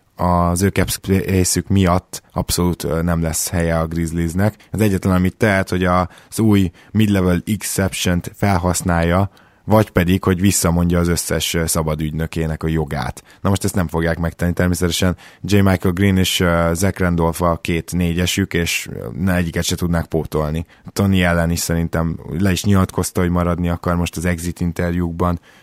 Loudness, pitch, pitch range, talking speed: -18 LUFS, 90 Hz, 85-95 Hz, 150 wpm